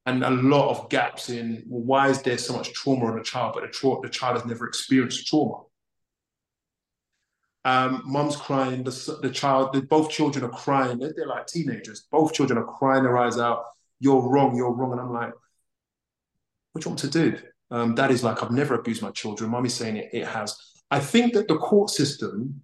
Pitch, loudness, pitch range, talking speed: 130 Hz, -24 LUFS, 120-140 Hz, 210 wpm